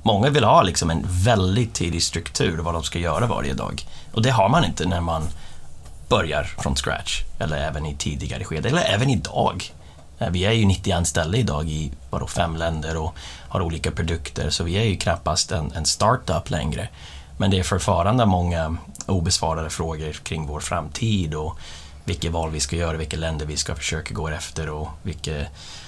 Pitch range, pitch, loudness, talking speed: 75-90 Hz, 80 Hz, -23 LUFS, 185 wpm